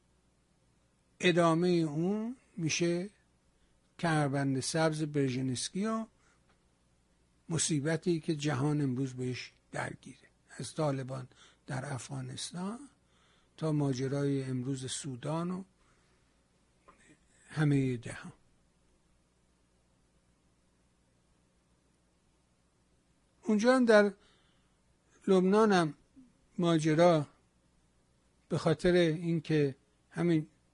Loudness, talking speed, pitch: -31 LUFS, 65 wpm, 140 Hz